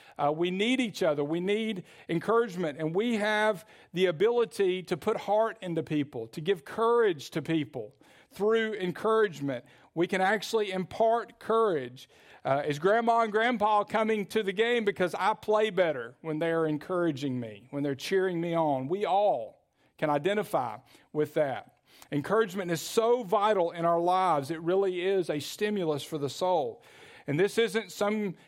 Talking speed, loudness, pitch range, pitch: 160 wpm, -29 LUFS, 160-215 Hz, 190 Hz